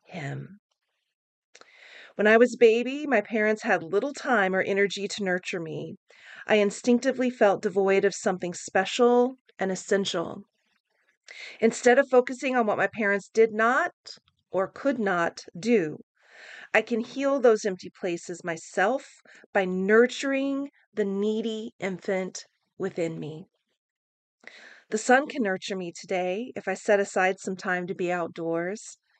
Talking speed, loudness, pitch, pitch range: 135 wpm, -26 LUFS, 200 Hz, 185-235 Hz